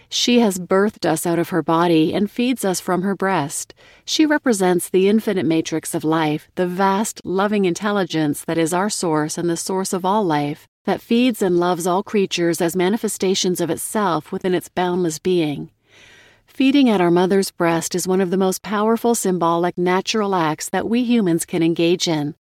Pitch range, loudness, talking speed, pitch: 170-205 Hz, -19 LUFS, 185 wpm, 185 Hz